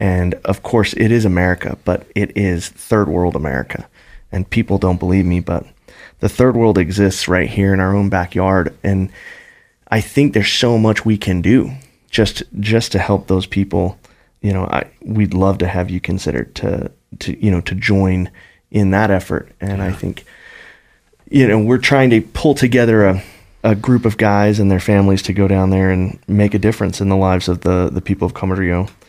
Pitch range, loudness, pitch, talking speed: 90-105 Hz, -16 LUFS, 100 Hz, 200 wpm